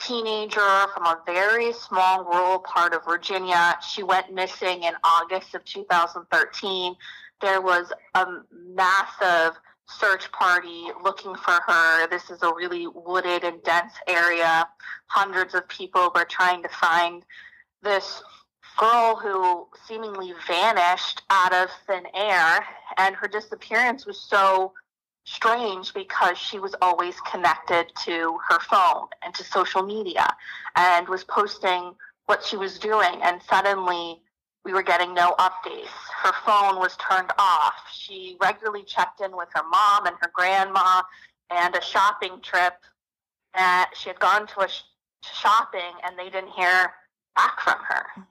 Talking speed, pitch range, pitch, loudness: 145 wpm, 175-200 Hz, 185 Hz, -22 LUFS